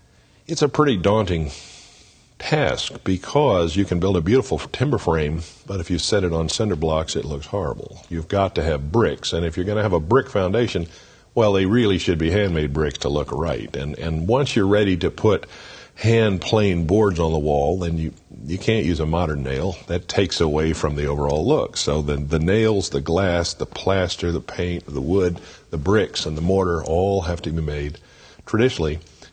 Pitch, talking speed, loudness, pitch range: 85 Hz, 205 wpm, -21 LUFS, 80-100 Hz